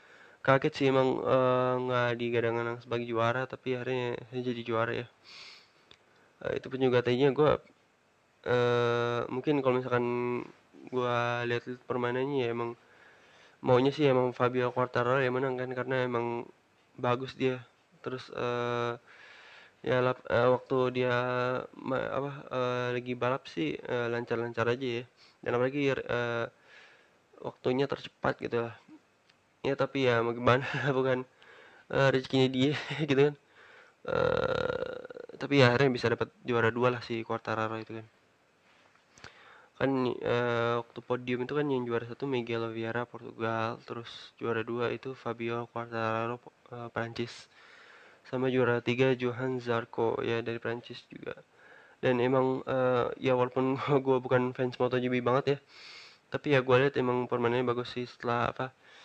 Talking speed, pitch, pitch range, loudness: 140 wpm, 125 Hz, 120-130 Hz, -30 LUFS